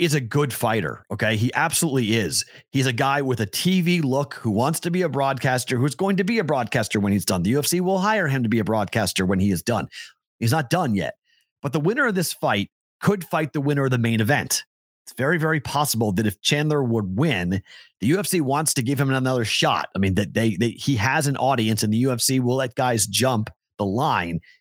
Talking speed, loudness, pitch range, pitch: 235 wpm, -22 LUFS, 110-155 Hz, 130 Hz